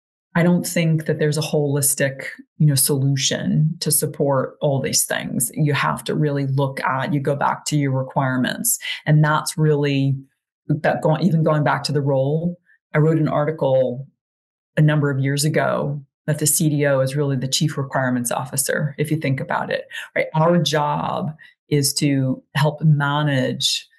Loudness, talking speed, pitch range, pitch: -20 LUFS, 170 wpm, 140-155 Hz, 150 Hz